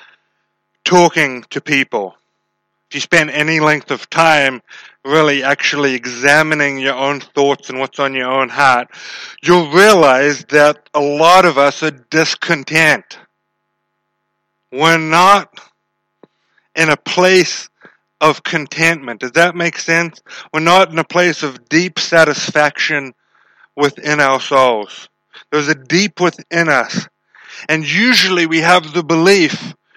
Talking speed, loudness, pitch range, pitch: 130 wpm, -12 LUFS, 140-170 Hz, 155 Hz